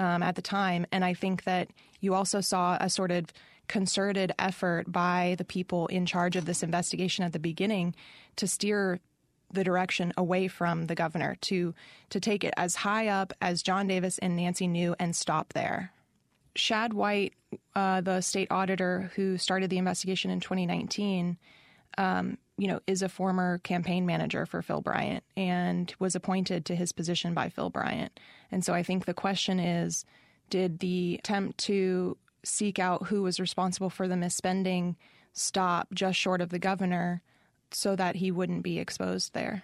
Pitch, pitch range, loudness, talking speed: 185 Hz, 175-190 Hz, -30 LUFS, 175 wpm